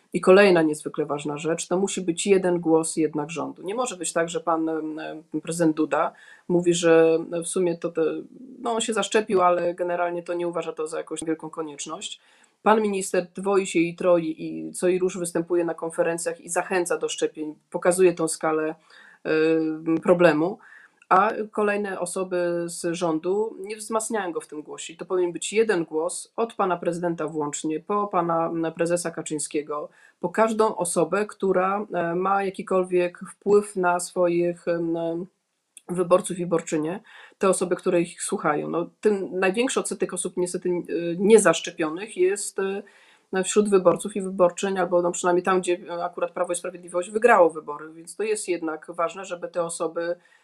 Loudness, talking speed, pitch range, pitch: -24 LUFS, 160 wpm, 165-190 Hz, 175 Hz